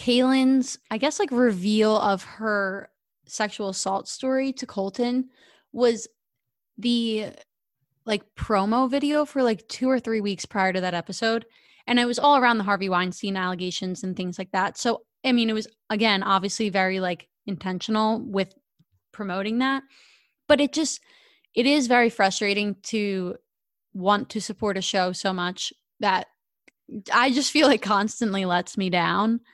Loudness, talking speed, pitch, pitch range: -24 LUFS, 155 wpm, 215 Hz, 195-245 Hz